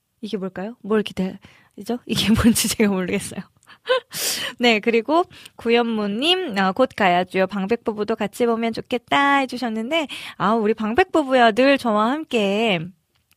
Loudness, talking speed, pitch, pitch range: -20 LUFS, 285 characters per minute, 225 Hz, 205-245 Hz